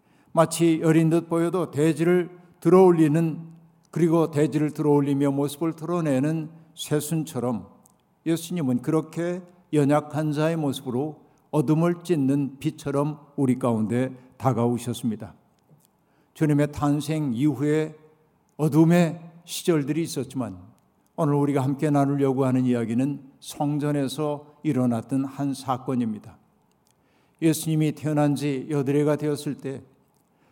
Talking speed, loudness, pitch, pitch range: 275 characters per minute, -24 LUFS, 150 Hz, 140-160 Hz